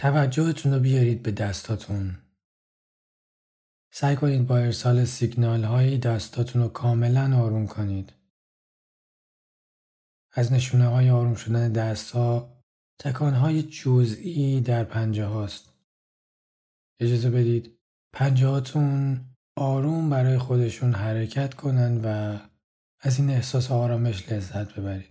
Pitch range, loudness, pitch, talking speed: 110-130 Hz, -24 LUFS, 120 Hz, 110 wpm